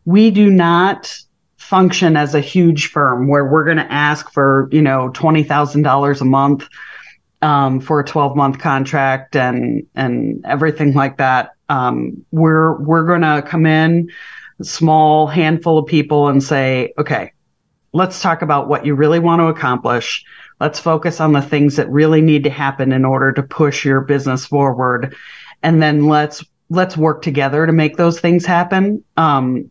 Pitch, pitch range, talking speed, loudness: 150 Hz, 140-165 Hz, 170 wpm, -14 LUFS